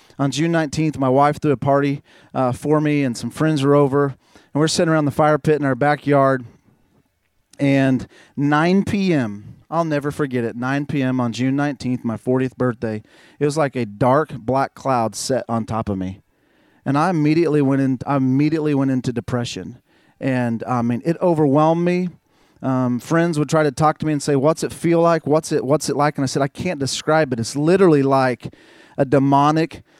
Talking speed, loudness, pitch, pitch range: 200 wpm, -19 LUFS, 140 Hz, 130-155 Hz